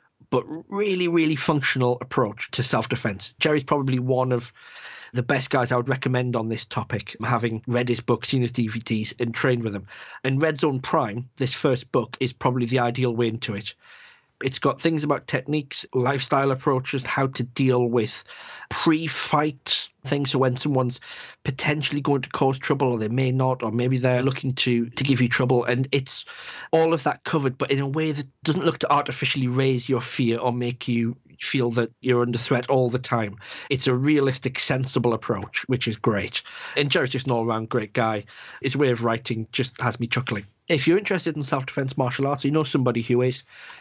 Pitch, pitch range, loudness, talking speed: 130 Hz, 120-140 Hz, -24 LUFS, 195 wpm